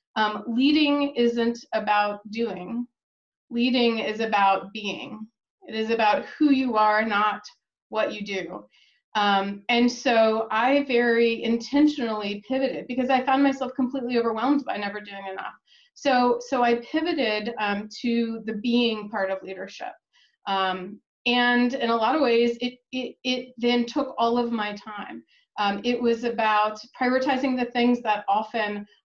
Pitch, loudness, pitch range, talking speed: 235 Hz, -24 LUFS, 215-250 Hz, 150 wpm